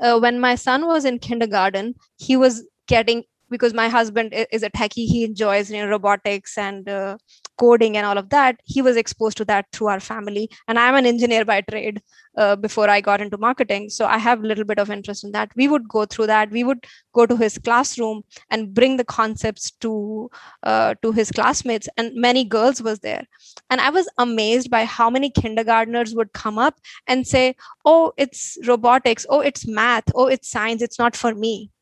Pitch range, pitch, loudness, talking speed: 215-250 Hz, 230 Hz, -19 LUFS, 205 wpm